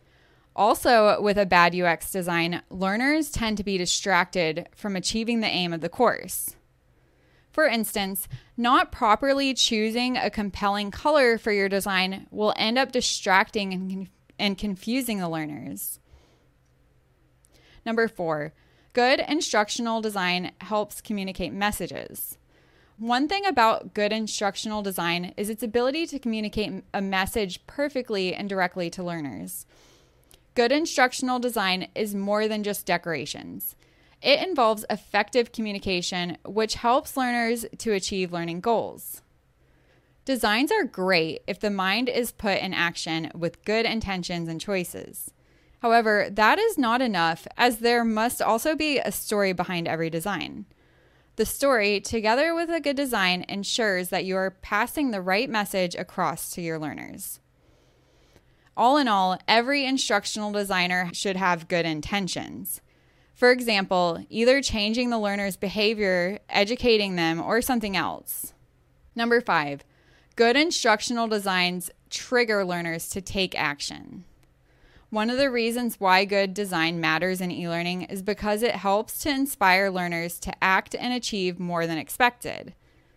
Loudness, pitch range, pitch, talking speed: -25 LUFS, 180-235 Hz, 205 Hz, 135 wpm